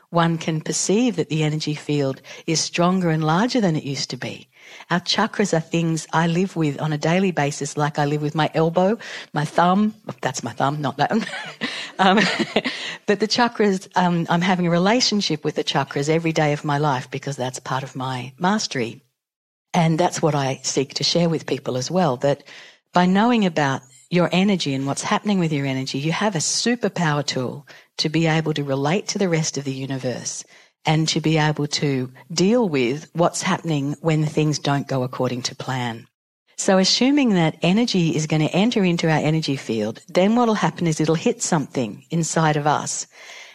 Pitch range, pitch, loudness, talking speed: 145-180 Hz, 160 Hz, -21 LUFS, 195 wpm